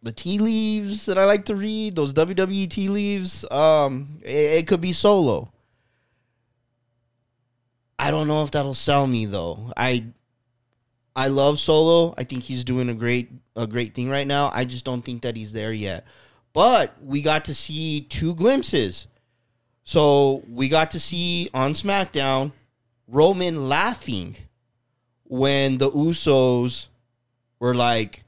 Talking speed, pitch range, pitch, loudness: 150 wpm, 120-160 Hz, 130 Hz, -21 LUFS